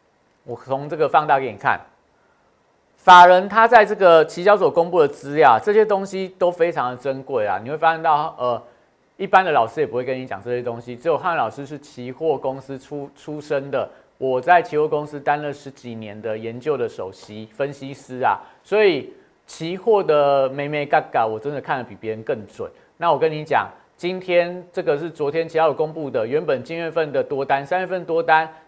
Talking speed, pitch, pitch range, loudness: 295 characters per minute, 150 Hz, 135-175 Hz, -19 LUFS